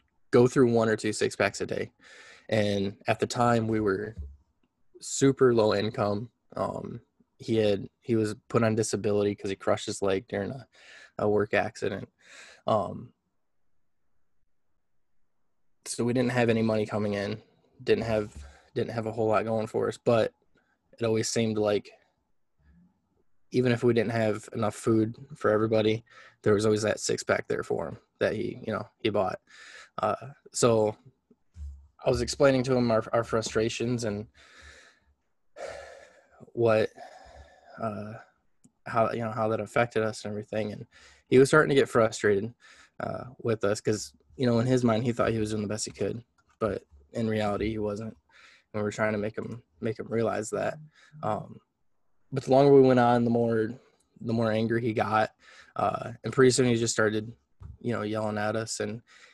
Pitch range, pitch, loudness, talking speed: 105-120 Hz, 110 Hz, -27 LUFS, 175 wpm